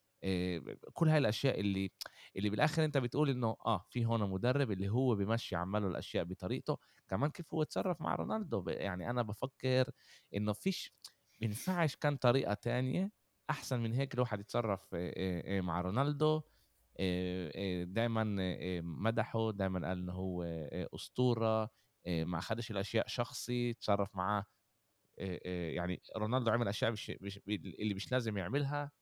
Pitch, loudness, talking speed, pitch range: 110 Hz, -36 LUFS, 130 wpm, 95-125 Hz